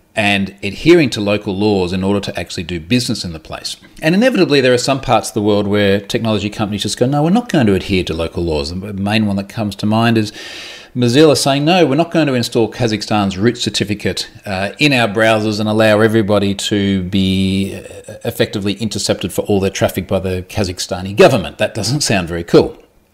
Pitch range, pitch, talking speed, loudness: 95-120 Hz, 105 Hz, 205 wpm, -15 LUFS